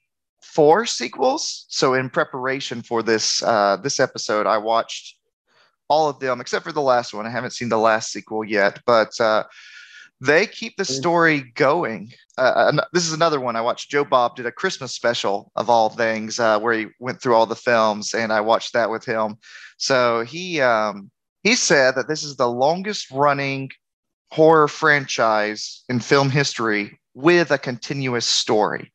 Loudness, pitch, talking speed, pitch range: -20 LUFS, 125 Hz, 175 wpm, 110-145 Hz